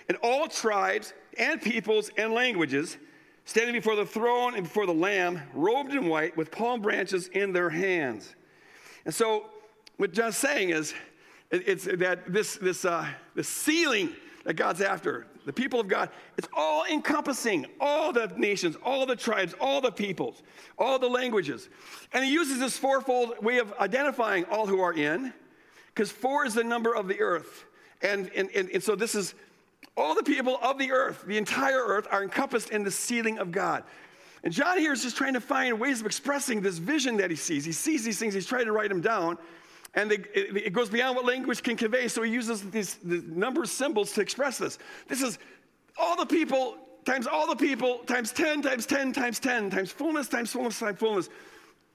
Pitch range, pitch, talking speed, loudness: 205-280 Hz, 240 Hz, 200 wpm, -28 LUFS